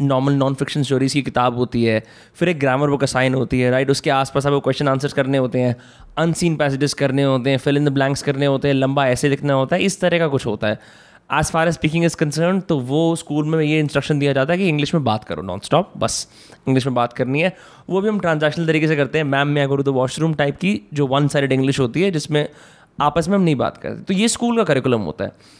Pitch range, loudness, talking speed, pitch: 130-160 Hz, -19 LUFS, 255 wpm, 140 Hz